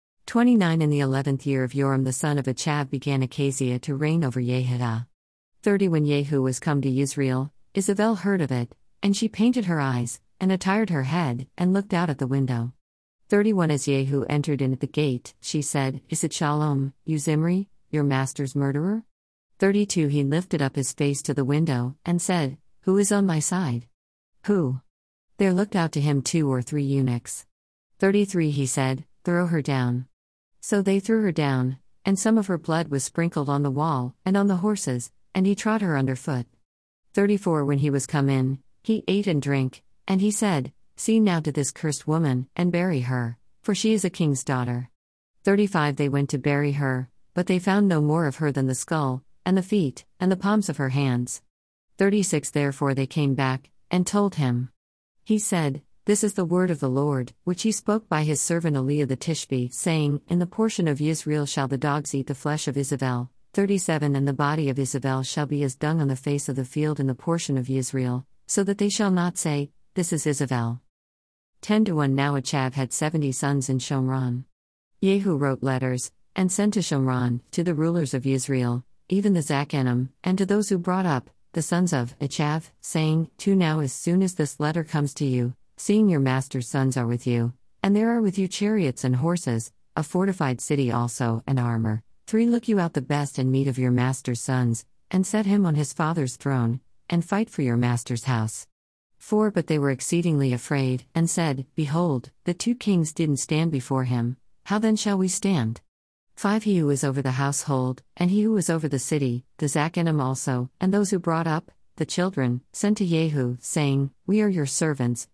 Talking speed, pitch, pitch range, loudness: 200 wpm, 145 Hz, 130-175 Hz, -24 LUFS